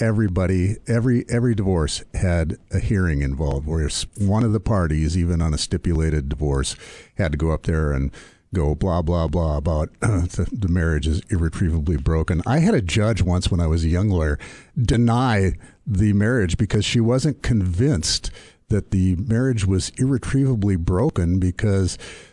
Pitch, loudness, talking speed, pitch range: 95 Hz, -21 LUFS, 165 wpm, 80-110 Hz